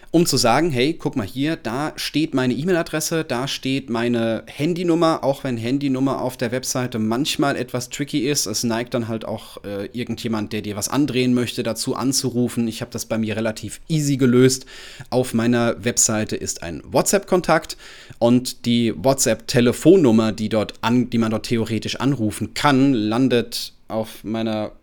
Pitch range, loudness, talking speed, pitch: 115-135 Hz, -20 LUFS, 165 wpm, 120 Hz